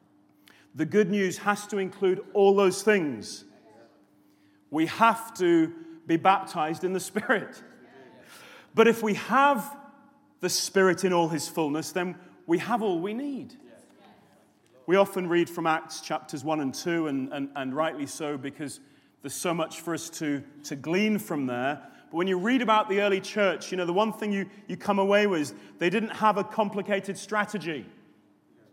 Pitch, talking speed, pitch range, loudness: 185 Hz, 175 wpm, 160-205 Hz, -27 LUFS